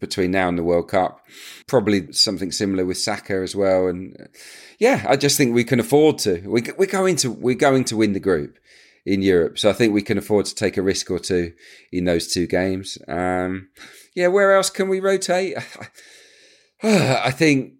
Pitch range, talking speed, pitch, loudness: 95-155 Hz, 195 wpm, 105 Hz, -20 LUFS